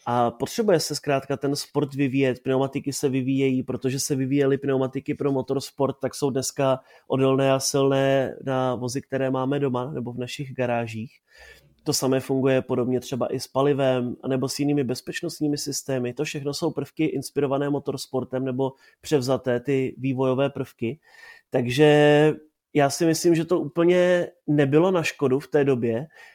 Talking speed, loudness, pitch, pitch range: 155 wpm, -24 LUFS, 135 Hz, 130-145 Hz